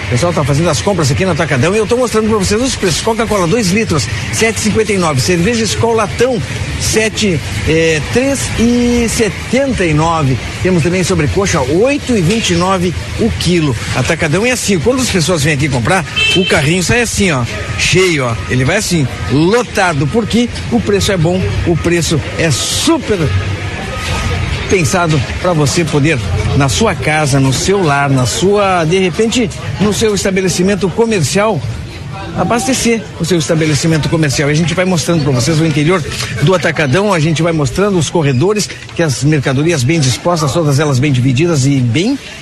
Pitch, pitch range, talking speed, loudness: 165 Hz, 140-200 Hz, 175 wpm, -12 LUFS